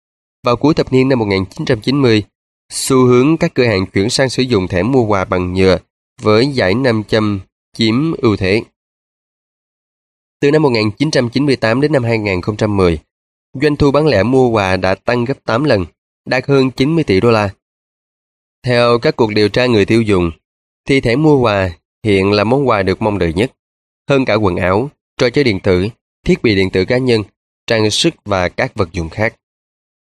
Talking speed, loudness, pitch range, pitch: 180 wpm, -14 LUFS, 95-130 Hz, 115 Hz